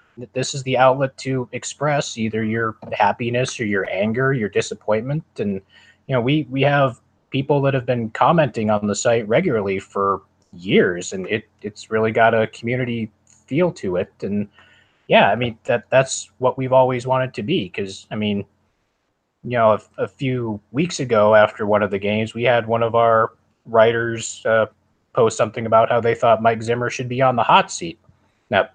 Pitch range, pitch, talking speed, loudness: 105-130 Hz, 115 Hz, 190 wpm, -19 LUFS